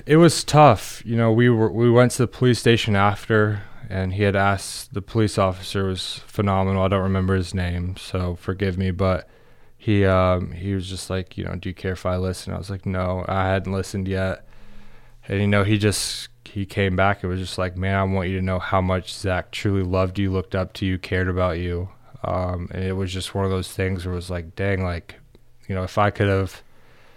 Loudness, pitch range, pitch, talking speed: -22 LUFS, 95-105 Hz, 95 Hz, 235 wpm